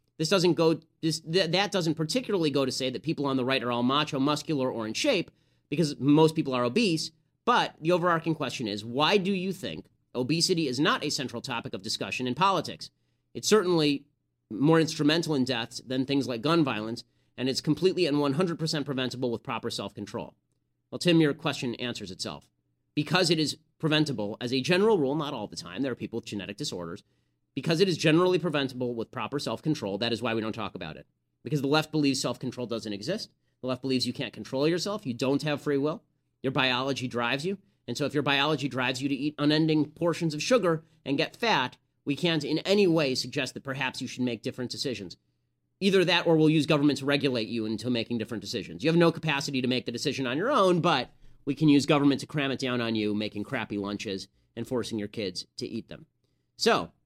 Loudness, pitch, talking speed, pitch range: -27 LUFS, 140 Hz, 220 wpm, 120-155 Hz